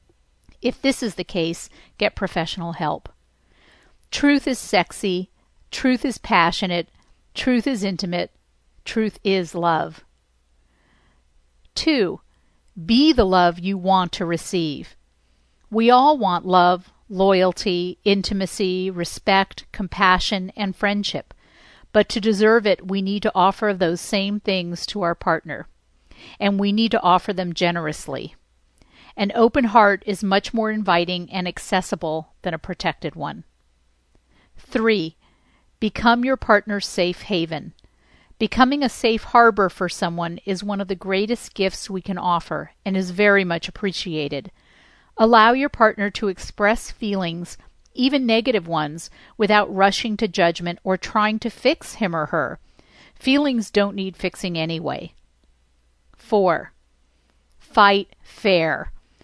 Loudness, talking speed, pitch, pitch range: -20 LUFS, 130 wpm, 190 Hz, 170-210 Hz